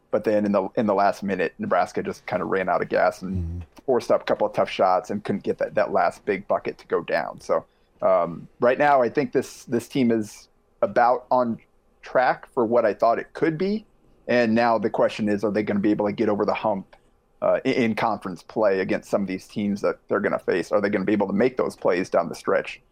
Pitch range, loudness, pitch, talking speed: 100-120 Hz, -23 LUFS, 105 Hz, 260 wpm